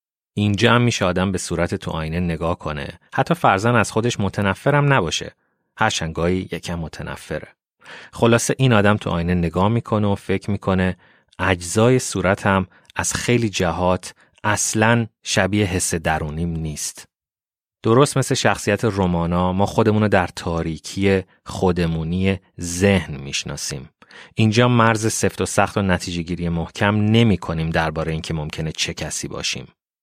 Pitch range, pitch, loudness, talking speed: 85-110 Hz, 95 Hz, -20 LUFS, 135 wpm